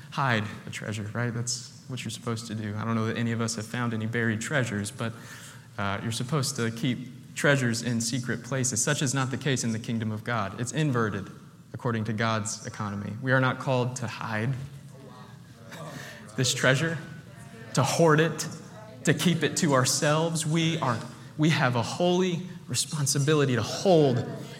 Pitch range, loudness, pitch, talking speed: 115-145 Hz, -27 LUFS, 130 Hz, 180 wpm